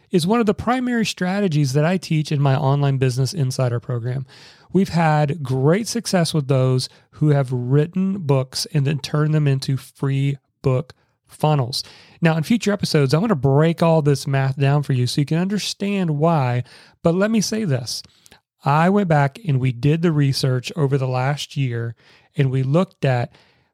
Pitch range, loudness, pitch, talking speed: 135-170 Hz, -20 LUFS, 145 Hz, 180 wpm